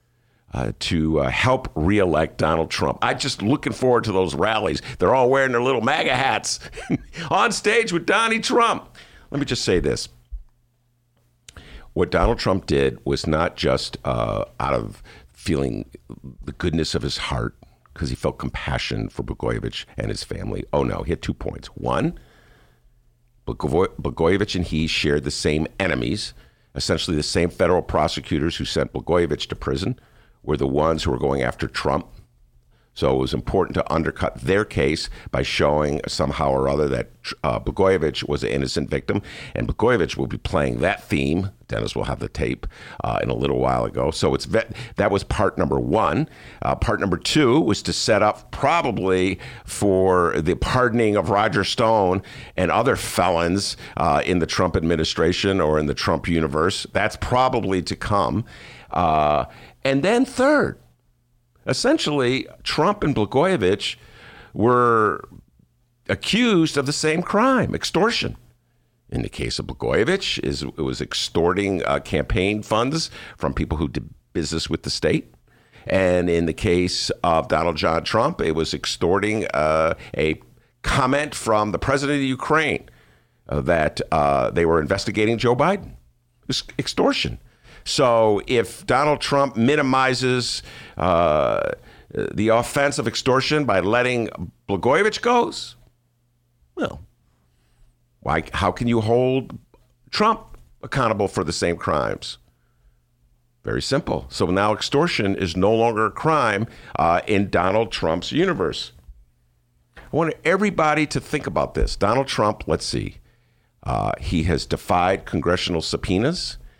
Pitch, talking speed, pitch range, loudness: 95 Hz, 145 wpm, 75-120 Hz, -21 LUFS